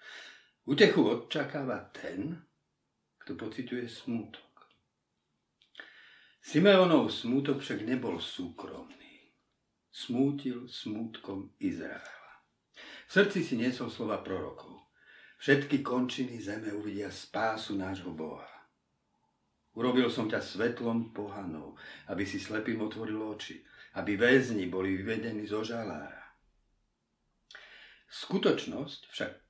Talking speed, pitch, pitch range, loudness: 90 wpm, 115 Hz, 105-125 Hz, -32 LUFS